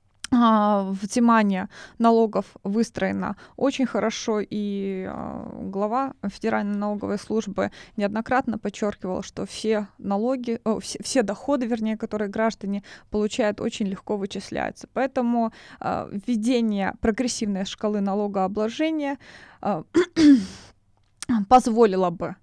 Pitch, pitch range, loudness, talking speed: 215 Hz, 200-240 Hz, -24 LUFS, 90 wpm